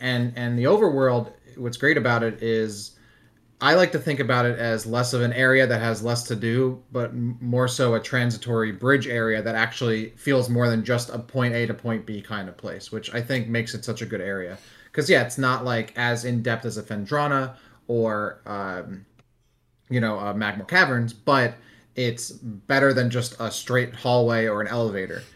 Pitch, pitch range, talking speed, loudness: 120 Hz, 110-125 Hz, 200 wpm, -23 LUFS